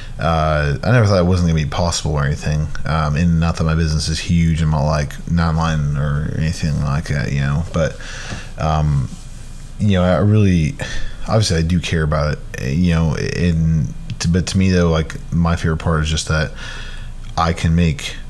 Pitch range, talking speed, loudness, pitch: 75-85 Hz, 195 wpm, -18 LUFS, 80 Hz